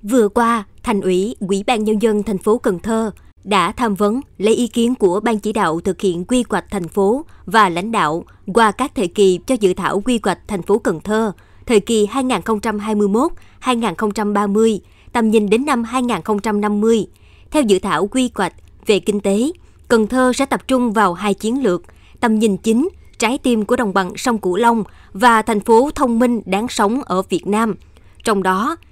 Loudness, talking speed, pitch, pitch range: -17 LUFS, 190 wpm, 220 Hz, 200-235 Hz